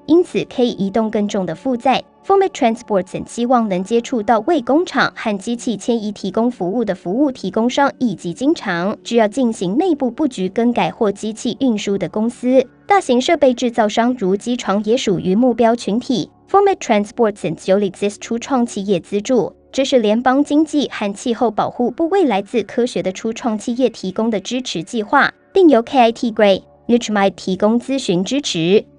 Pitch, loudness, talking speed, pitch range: 235 Hz, -17 LUFS, 350 characters per minute, 205-255 Hz